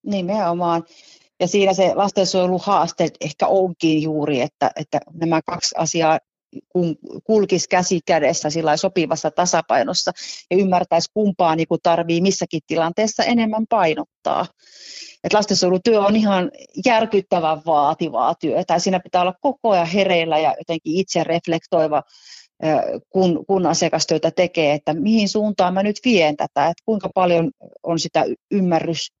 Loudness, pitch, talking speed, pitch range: -19 LUFS, 175 Hz, 130 wpm, 165-195 Hz